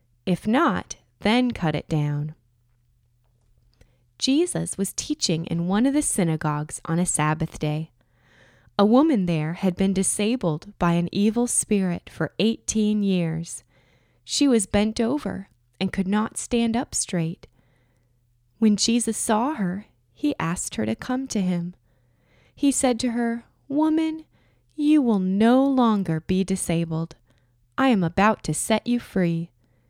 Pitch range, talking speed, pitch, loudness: 145-225 Hz, 140 wpm, 180 Hz, -23 LUFS